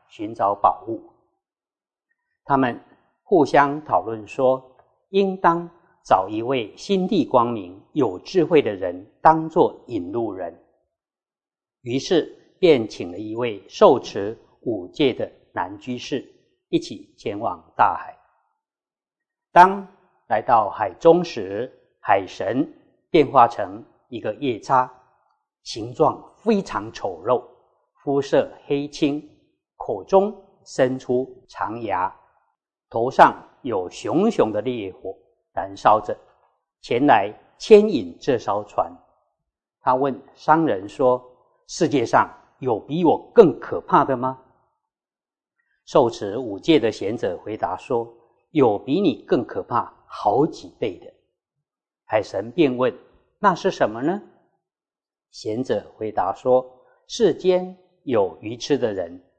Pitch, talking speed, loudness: 180 Hz, 160 characters per minute, -21 LUFS